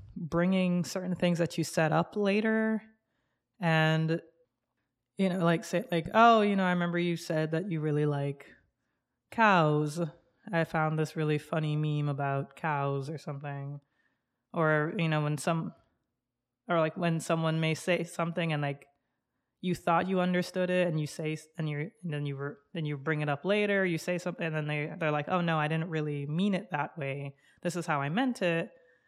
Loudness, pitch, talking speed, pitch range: -30 LUFS, 160 Hz, 190 wpm, 150-175 Hz